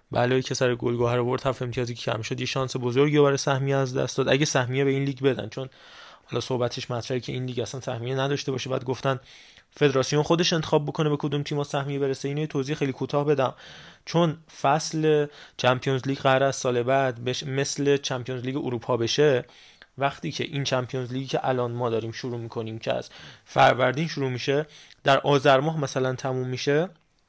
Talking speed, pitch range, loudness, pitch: 190 wpm, 125-145 Hz, -25 LUFS, 135 Hz